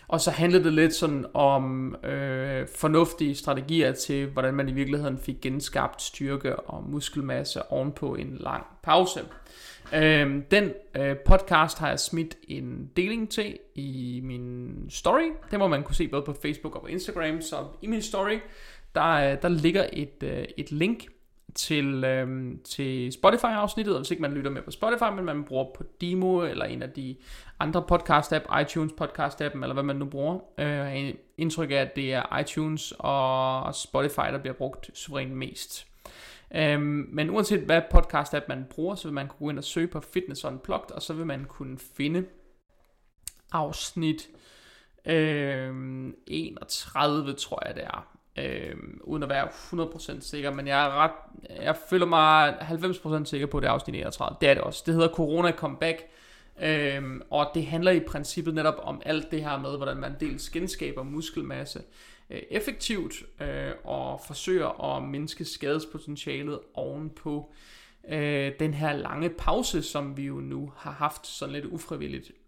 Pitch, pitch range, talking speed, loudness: 150 Hz, 140-165 Hz, 170 wpm, -28 LUFS